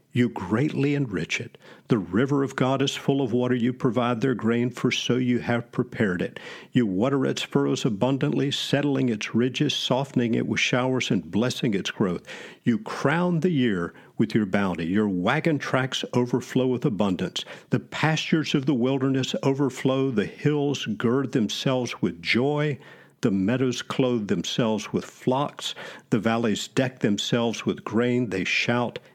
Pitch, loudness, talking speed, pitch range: 125 Hz, -25 LUFS, 160 wpm, 120-140 Hz